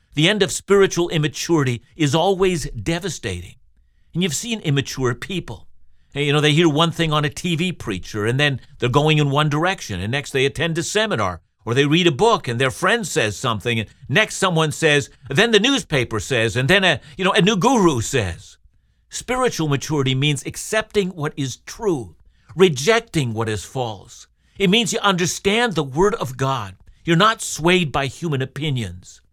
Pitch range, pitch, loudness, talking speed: 120-180 Hz, 150 Hz, -19 LUFS, 180 wpm